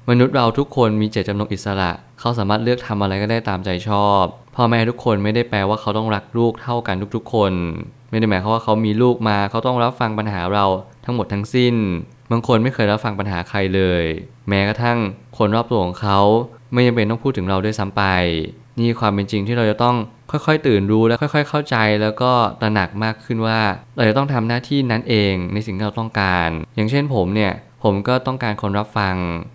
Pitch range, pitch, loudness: 100-120 Hz, 110 Hz, -19 LUFS